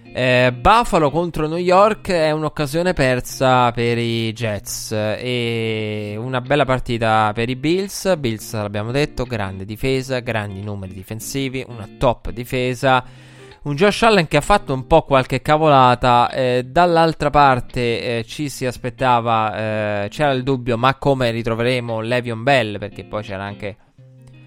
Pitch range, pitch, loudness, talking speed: 115-140 Hz, 125 Hz, -18 LUFS, 145 wpm